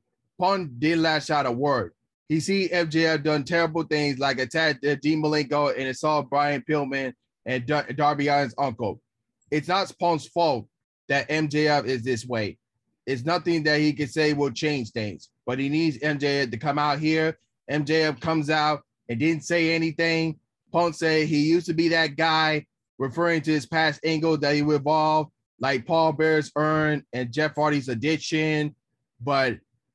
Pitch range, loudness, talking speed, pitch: 140-160 Hz, -24 LUFS, 170 wpm, 150 Hz